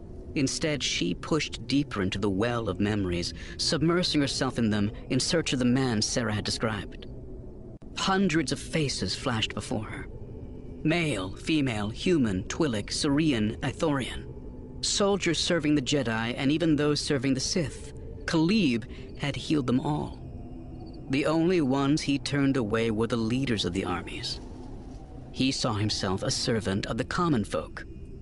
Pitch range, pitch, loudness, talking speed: 105-145 Hz, 130 Hz, -27 LUFS, 145 wpm